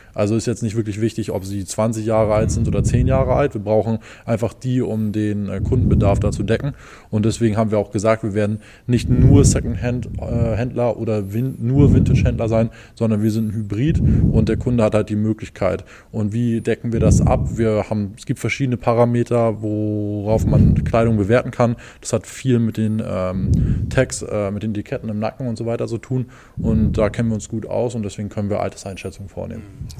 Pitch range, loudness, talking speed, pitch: 105-120 Hz, -19 LUFS, 205 wpm, 110 Hz